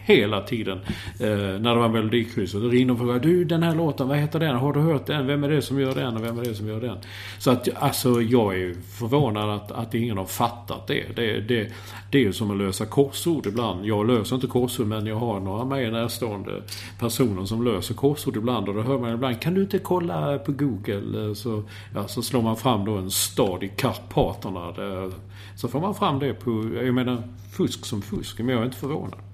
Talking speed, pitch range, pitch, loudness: 225 wpm, 105-130 Hz, 115 Hz, -25 LUFS